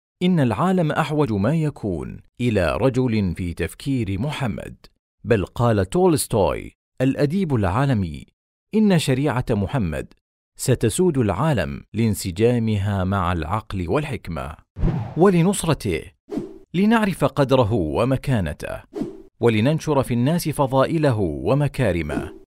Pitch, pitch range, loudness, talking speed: 125 Hz, 100-150 Hz, -21 LUFS, 90 wpm